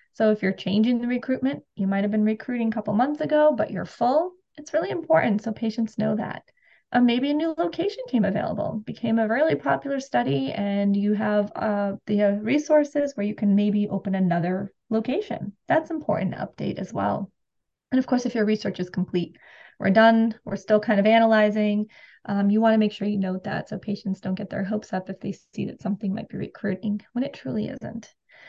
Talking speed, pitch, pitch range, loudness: 210 wpm, 215 Hz, 200-245 Hz, -24 LUFS